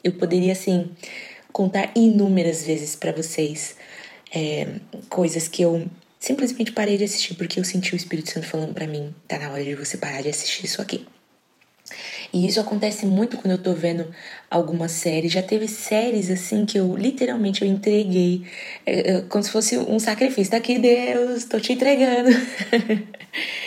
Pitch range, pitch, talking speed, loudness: 170-220 Hz, 190 Hz, 165 wpm, -22 LUFS